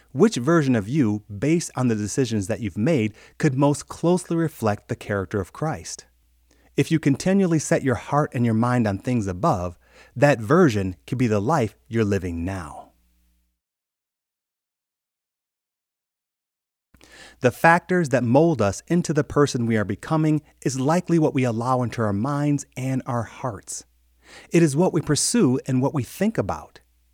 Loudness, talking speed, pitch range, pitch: -22 LUFS, 160 wpm, 105-155 Hz, 125 Hz